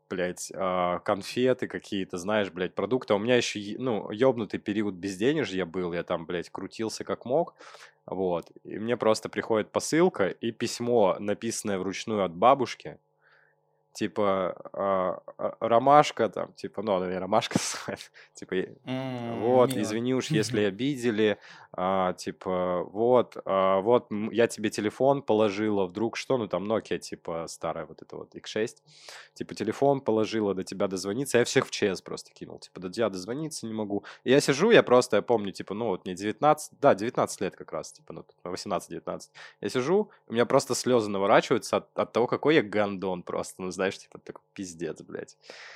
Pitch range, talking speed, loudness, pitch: 95-120 Hz, 165 wpm, -27 LUFS, 110 Hz